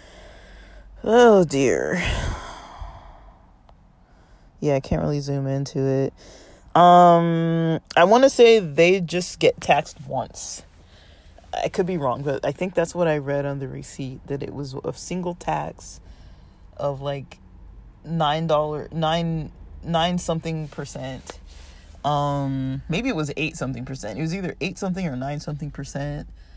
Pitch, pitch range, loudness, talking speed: 145 Hz, 135-170 Hz, -22 LUFS, 140 wpm